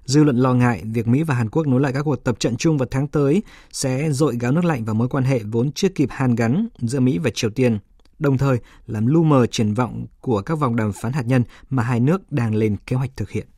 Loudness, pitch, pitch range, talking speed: -20 LUFS, 130 Hz, 115-145 Hz, 270 wpm